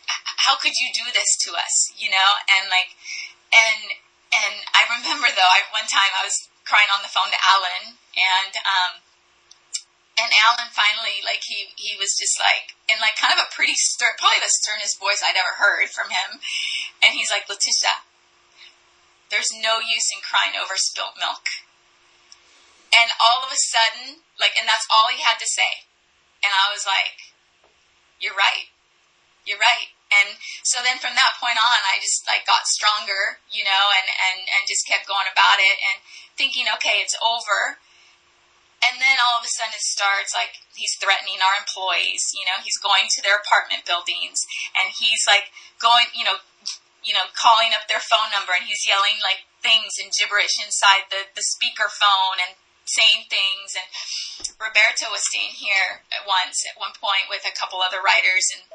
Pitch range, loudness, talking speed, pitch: 195-230 Hz, -19 LUFS, 185 wpm, 210 Hz